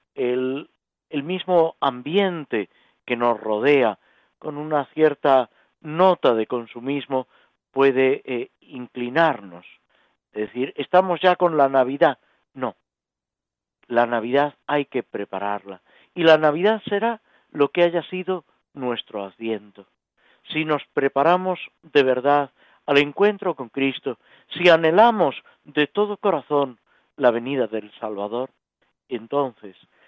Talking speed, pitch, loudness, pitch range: 115 wpm, 140 Hz, -21 LUFS, 125-165 Hz